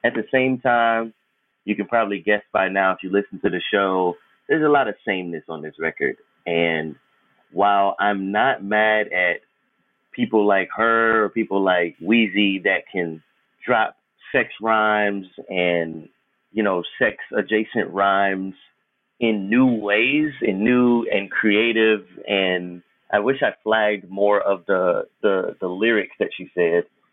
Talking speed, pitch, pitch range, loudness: 155 wpm, 105 Hz, 95-115 Hz, -20 LUFS